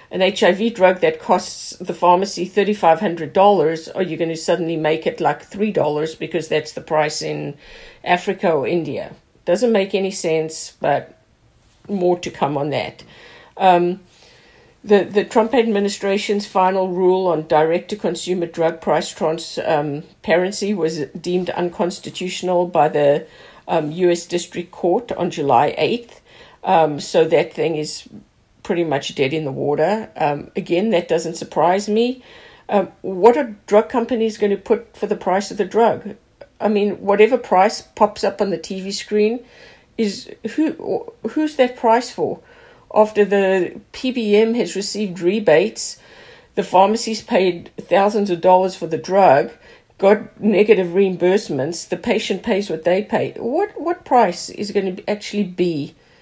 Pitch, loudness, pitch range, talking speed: 190 Hz, -18 LUFS, 170-210 Hz, 155 wpm